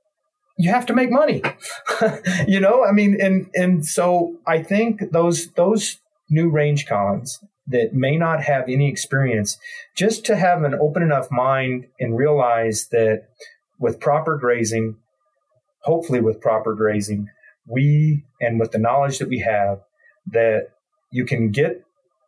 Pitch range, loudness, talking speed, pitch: 120-190 Hz, -19 LUFS, 145 wpm, 150 Hz